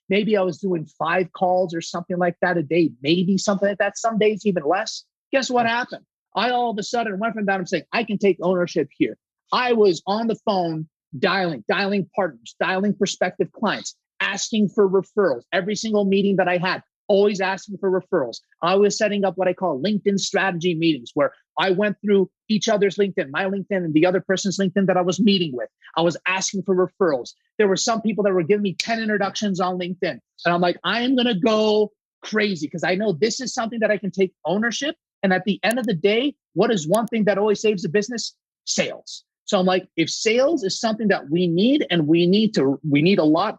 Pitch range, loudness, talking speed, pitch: 180-215 Hz, -21 LUFS, 225 wpm, 195 Hz